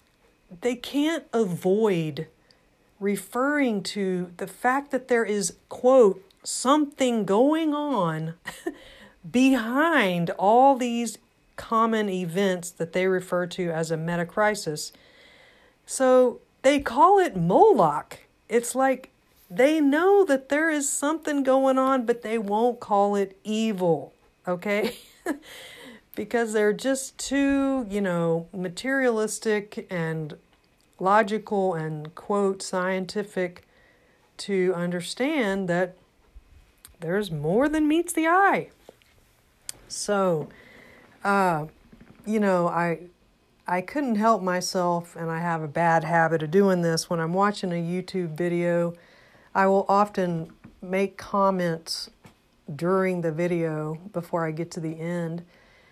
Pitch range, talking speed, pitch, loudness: 175-250 Hz, 115 wpm, 195 Hz, -24 LUFS